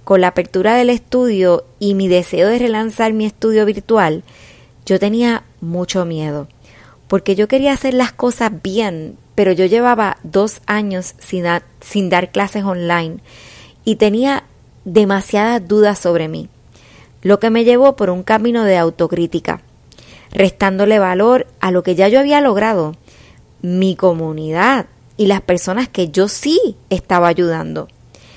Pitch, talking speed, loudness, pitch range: 195 Hz, 145 wpm, -15 LUFS, 180-225 Hz